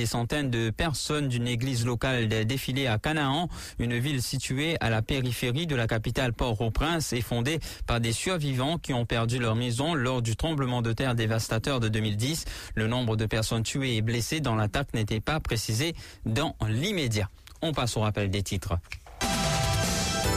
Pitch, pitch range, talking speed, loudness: 120 Hz, 110-140 Hz, 170 wpm, -28 LUFS